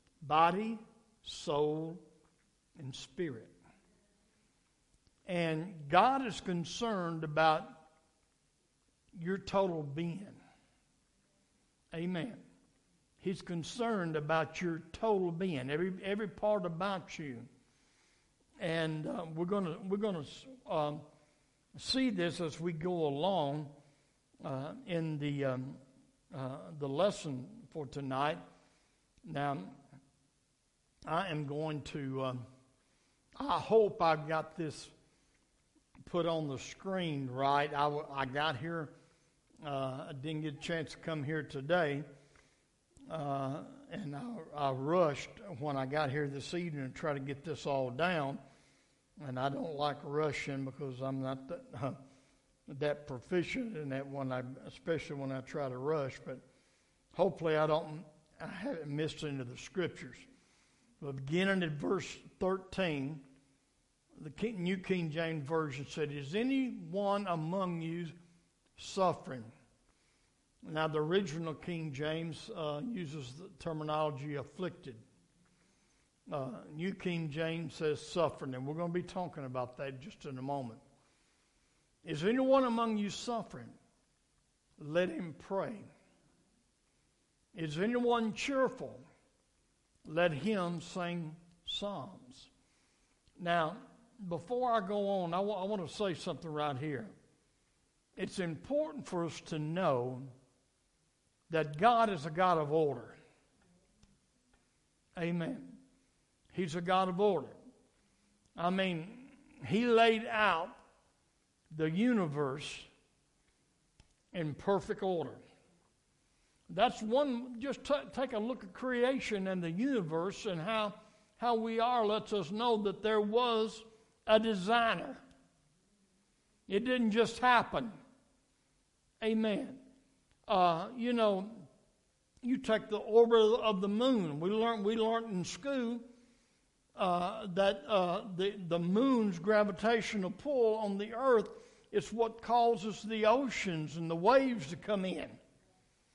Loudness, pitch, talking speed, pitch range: -35 LUFS, 170 Hz, 120 wpm, 150-210 Hz